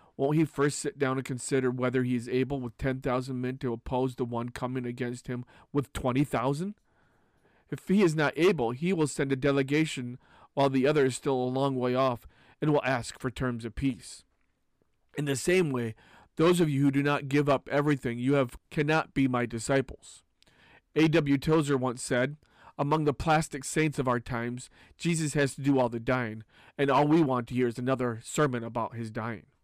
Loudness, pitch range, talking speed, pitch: -29 LUFS, 125-145 Hz, 205 wpm, 135 Hz